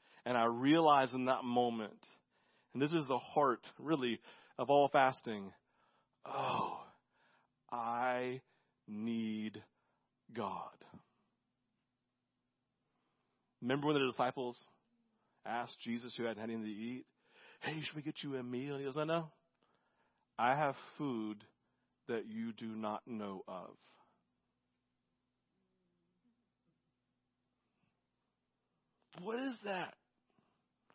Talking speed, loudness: 105 wpm, -38 LUFS